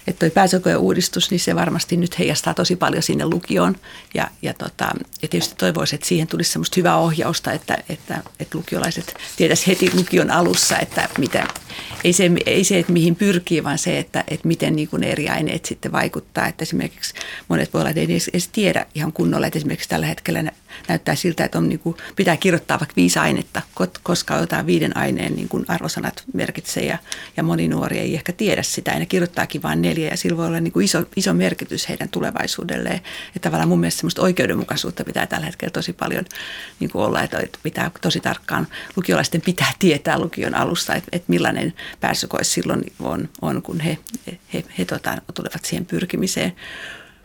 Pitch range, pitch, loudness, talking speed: 160-180 Hz, 170 Hz, -20 LUFS, 190 wpm